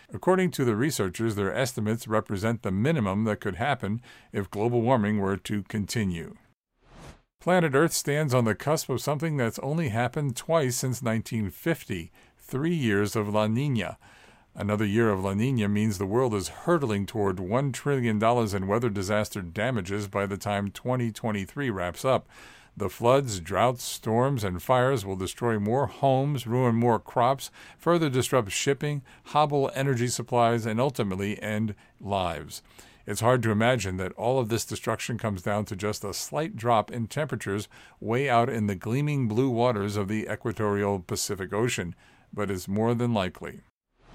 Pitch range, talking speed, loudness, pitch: 105-130 Hz, 160 wpm, -27 LUFS, 115 Hz